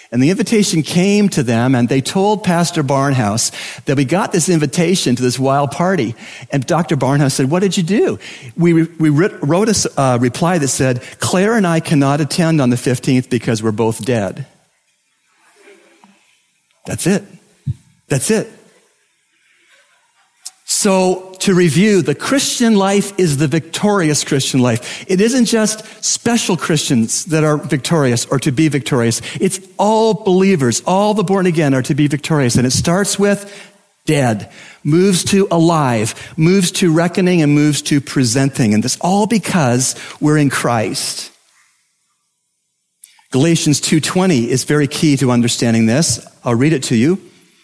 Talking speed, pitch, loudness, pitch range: 155 wpm, 155 Hz, -14 LUFS, 135-190 Hz